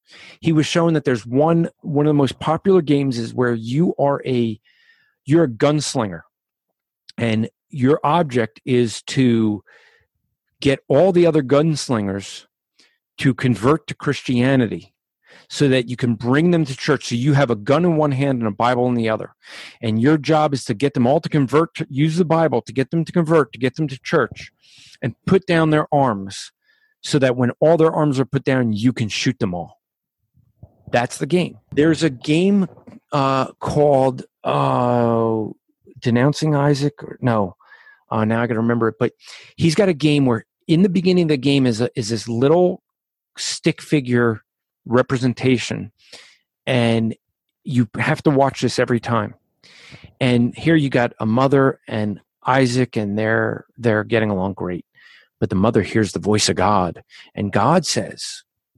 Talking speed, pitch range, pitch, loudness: 175 wpm, 115-155 Hz, 130 Hz, -19 LUFS